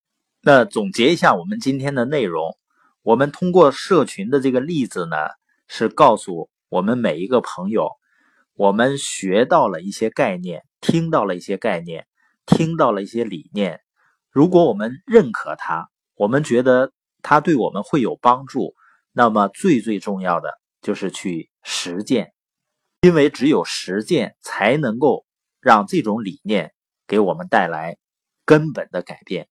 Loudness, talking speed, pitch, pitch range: -19 LUFS, 230 characters per minute, 130 Hz, 105-155 Hz